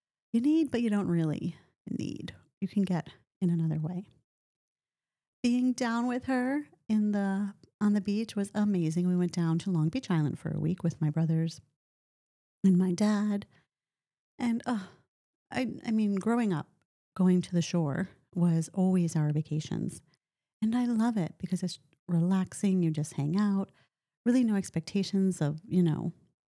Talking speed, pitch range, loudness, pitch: 165 wpm, 165-210 Hz, -30 LUFS, 185 Hz